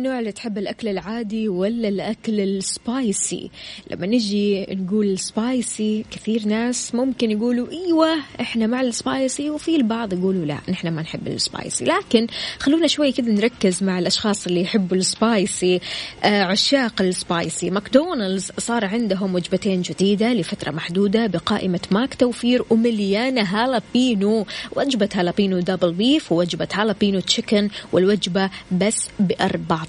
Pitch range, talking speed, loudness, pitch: 190-235 Hz, 125 wpm, -21 LUFS, 210 Hz